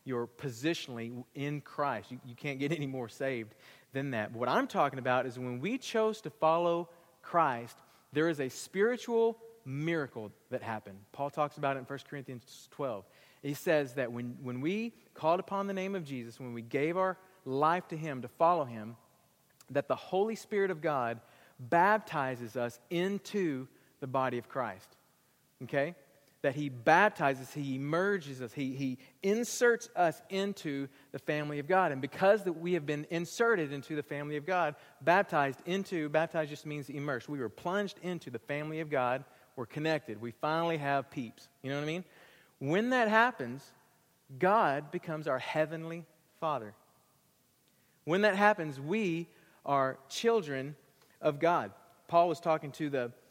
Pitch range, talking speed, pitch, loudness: 130-175 Hz, 170 wpm, 150 Hz, -33 LUFS